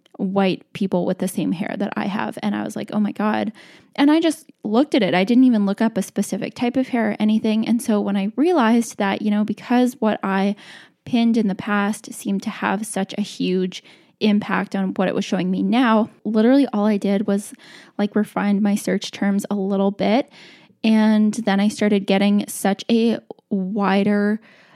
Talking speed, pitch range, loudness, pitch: 205 wpm, 195-230 Hz, -20 LUFS, 210 Hz